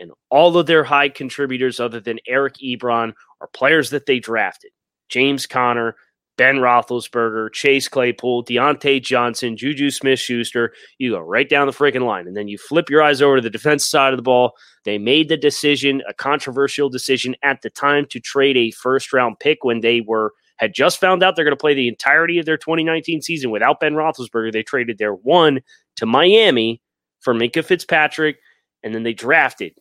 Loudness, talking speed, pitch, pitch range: -17 LUFS, 190 wpm, 130 Hz, 120-145 Hz